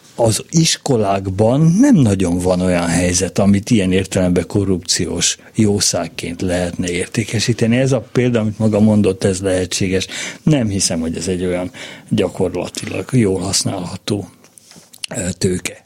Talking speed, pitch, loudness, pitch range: 120 wpm, 100 Hz, -16 LUFS, 90-110 Hz